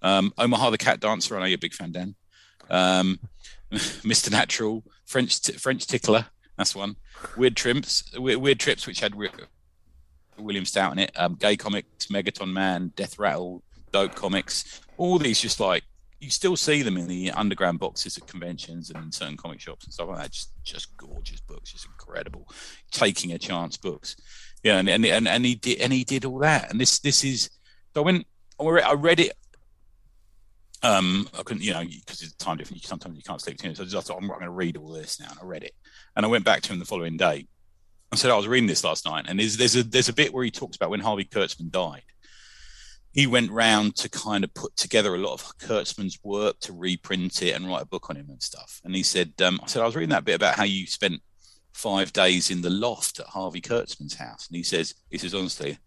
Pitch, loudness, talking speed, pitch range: 95 Hz, -24 LUFS, 230 wpm, 90-120 Hz